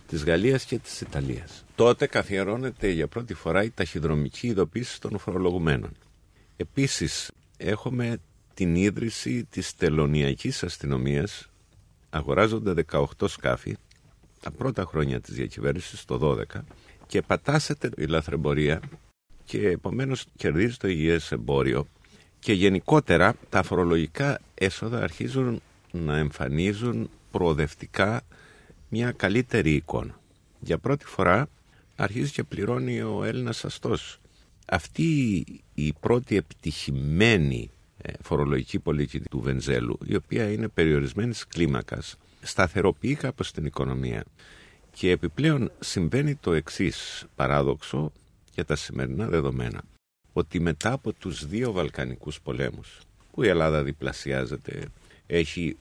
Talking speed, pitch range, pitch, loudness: 110 wpm, 75-115 Hz, 90 Hz, -27 LUFS